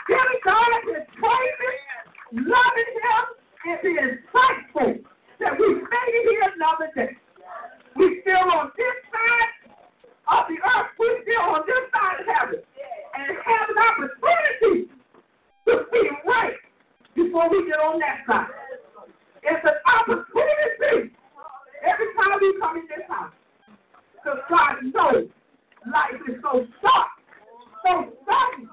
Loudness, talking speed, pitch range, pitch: -21 LUFS, 130 wpm, 300-465 Hz, 375 Hz